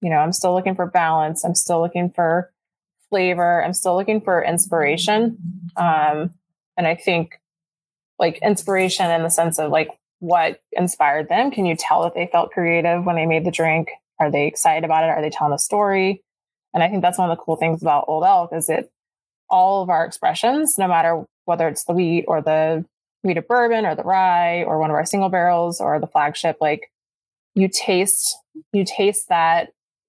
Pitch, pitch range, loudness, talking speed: 170 Hz, 165-190 Hz, -19 LUFS, 200 wpm